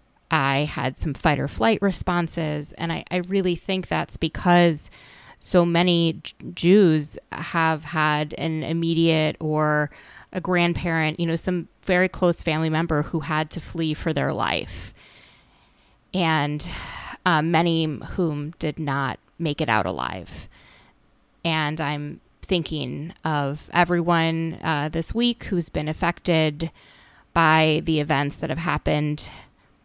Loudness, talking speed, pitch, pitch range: -23 LUFS, 130 wpm, 160 Hz, 150-170 Hz